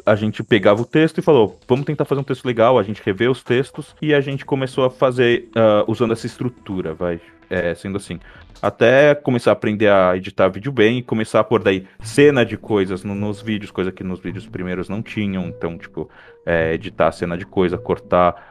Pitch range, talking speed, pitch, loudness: 95-125 Hz, 215 wpm, 110 Hz, -18 LUFS